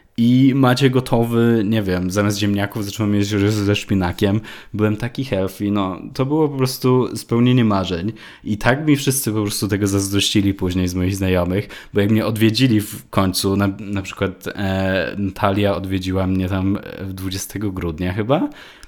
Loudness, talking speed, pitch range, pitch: -19 LUFS, 160 wpm, 95-115 Hz, 105 Hz